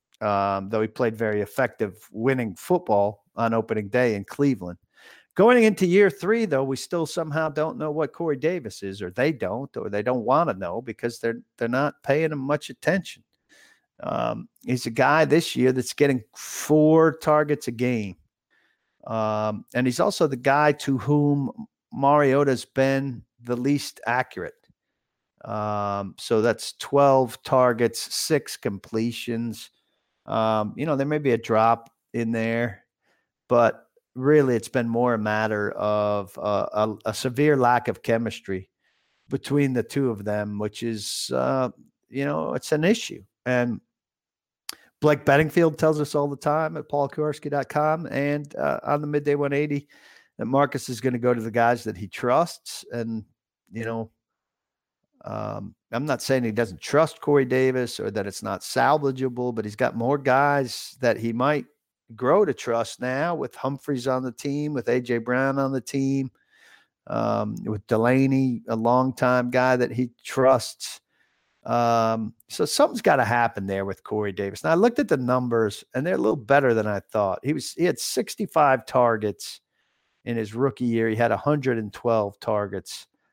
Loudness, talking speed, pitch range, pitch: -24 LUFS, 165 wpm, 115-145 Hz, 125 Hz